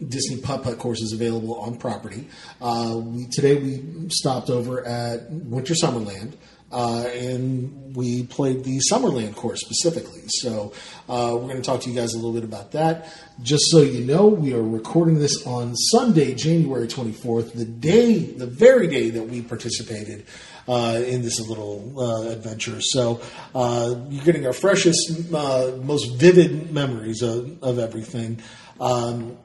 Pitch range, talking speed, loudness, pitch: 115-145 Hz, 160 wpm, -22 LUFS, 125 Hz